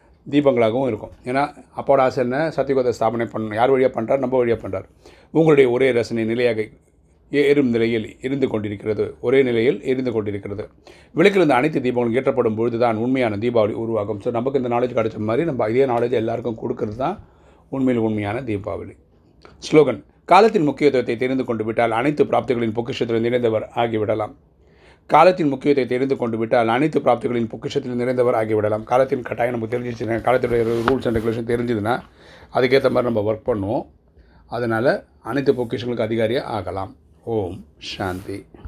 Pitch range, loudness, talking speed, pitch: 110-130 Hz, -20 LUFS, 145 wpm, 120 Hz